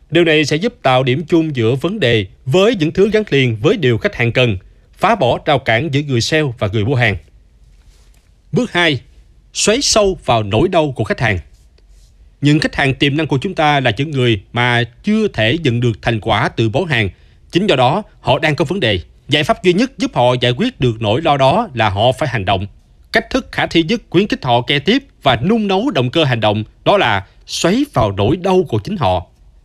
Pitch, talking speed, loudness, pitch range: 130 Hz, 230 wpm, -15 LUFS, 110-165 Hz